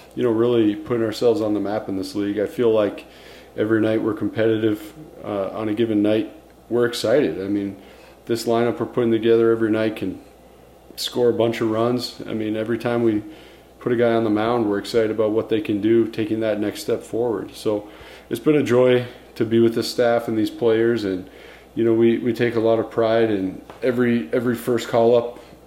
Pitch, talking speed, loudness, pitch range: 115 Hz, 215 wpm, -21 LUFS, 110-120 Hz